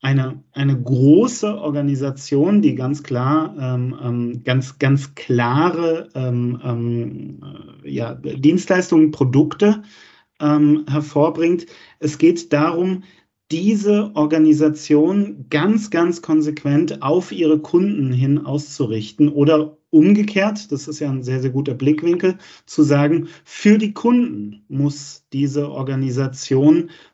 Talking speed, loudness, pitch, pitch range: 110 wpm, -18 LUFS, 150 Hz, 135-170 Hz